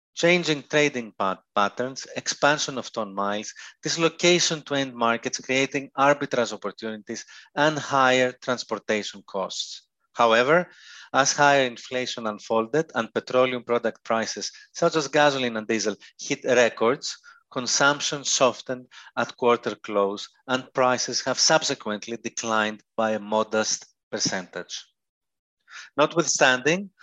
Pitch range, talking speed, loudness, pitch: 110-145 Hz, 110 wpm, -24 LUFS, 125 Hz